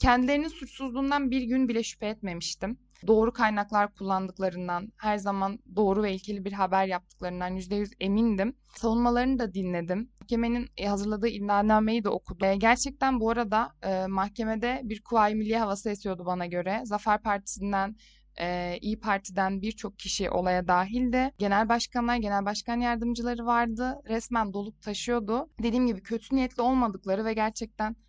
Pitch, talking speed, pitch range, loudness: 215 Hz, 140 wpm, 195-235 Hz, -28 LUFS